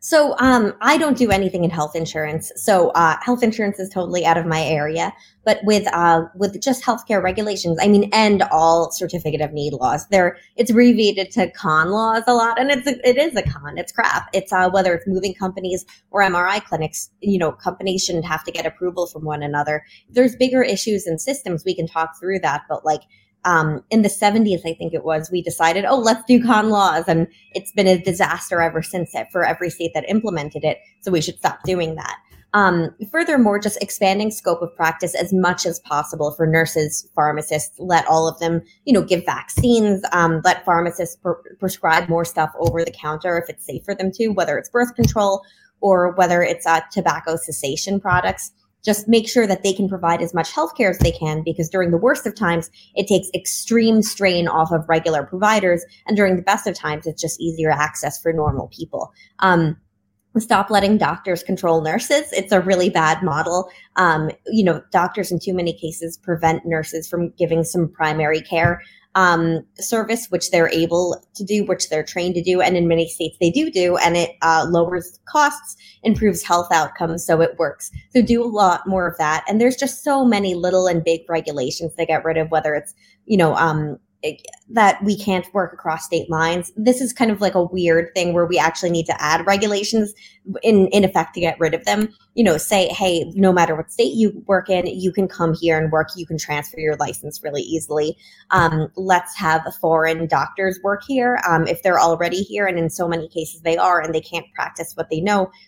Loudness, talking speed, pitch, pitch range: -19 LUFS, 210 wpm, 180 Hz, 165-200 Hz